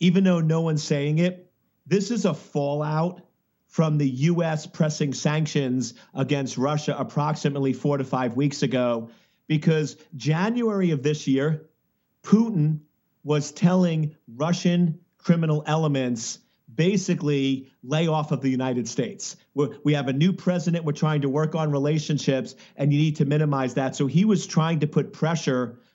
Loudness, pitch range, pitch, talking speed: -24 LUFS, 140-165 Hz, 150 Hz, 155 wpm